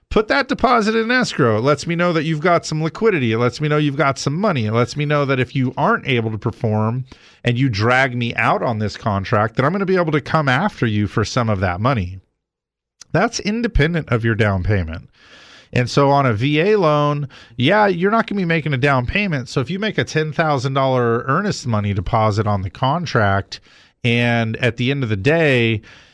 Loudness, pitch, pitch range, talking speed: -18 LUFS, 135 Hz, 115-160 Hz, 225 wpm